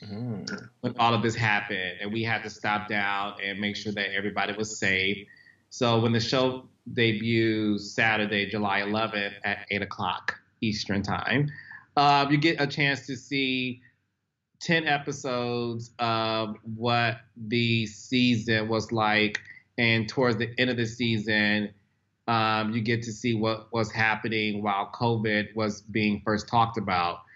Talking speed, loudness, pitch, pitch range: 150 wpm, -26 LUFS, 110 Hz, 105-120 Hz